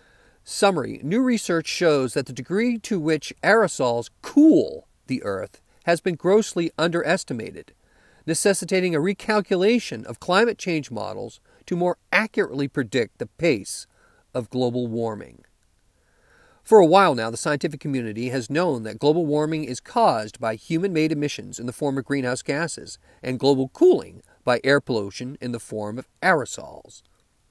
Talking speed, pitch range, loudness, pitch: 150 wpm, 125-185 Hz, -22 LUFS, 150 Hz